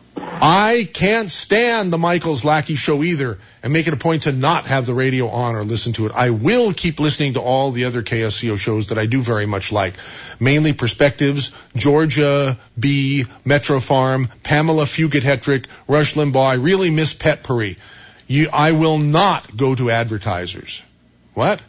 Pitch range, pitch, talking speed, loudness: 120-155 Hz, 140 Hz, 170 wpm, -17 LUFS